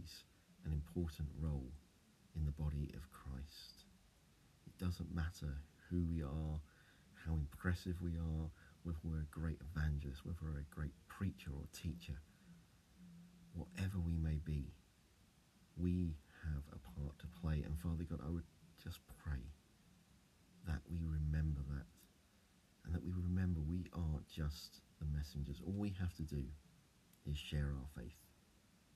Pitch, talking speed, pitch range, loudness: 80 Hz, 140 wpm, 75-90 Hz, -46 LUFS